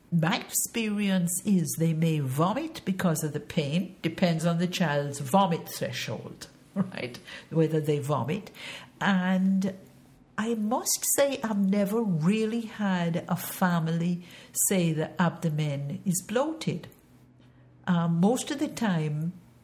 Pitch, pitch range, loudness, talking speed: 180 Hz, 165-200 Hz, -28 LUFS, 120 wpm